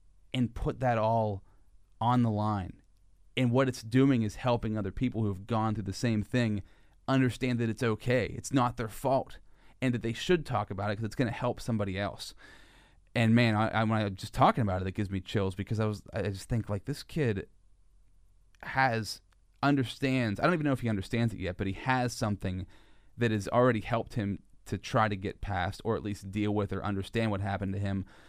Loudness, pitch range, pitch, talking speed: -31 LUFS, 95-120 Hz, 105 Hz, 215 wpm